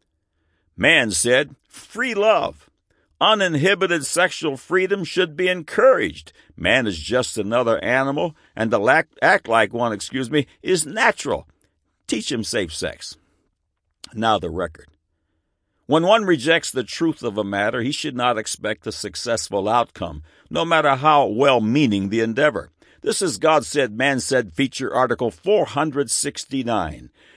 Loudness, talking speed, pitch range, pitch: -20 LUFS, 135 wpm, 105-165 Hz, 130 Hz